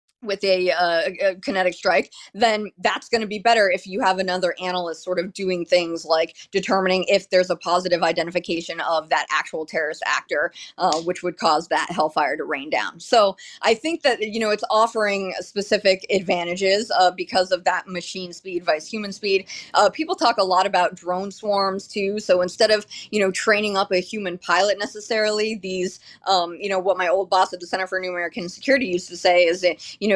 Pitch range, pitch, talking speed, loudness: 180-210 Hz, 190 Hz, 205 wpm, -21 LUFS